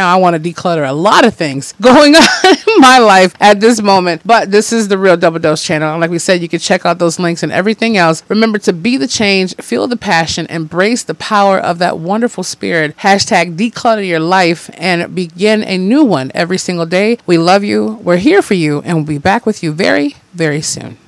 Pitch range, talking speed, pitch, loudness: 170-220 Hz, 230 wpm, 185 Hz, -10 LUFS